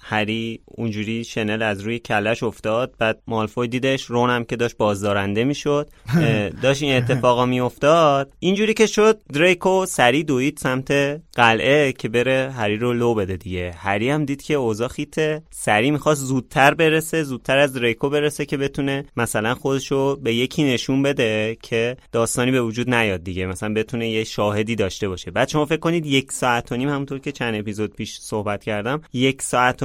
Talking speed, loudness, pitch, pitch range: 170 wpm, -20 LUFS, 125 Hz, 110-140 Hz